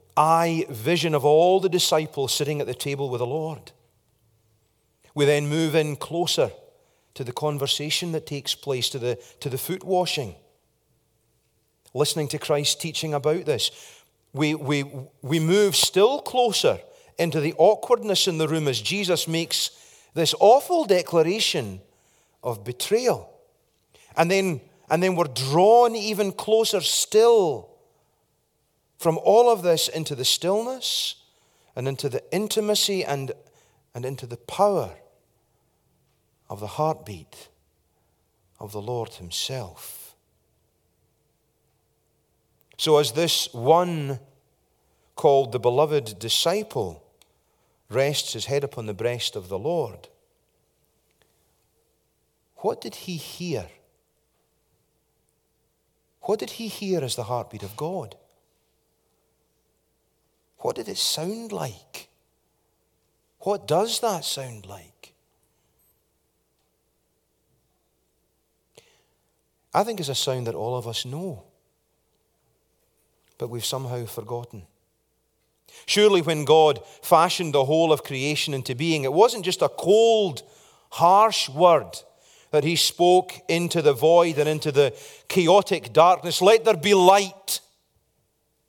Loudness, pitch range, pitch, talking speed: -22 LUFS, 125-180 Hz, 150 Hz, 120 wpm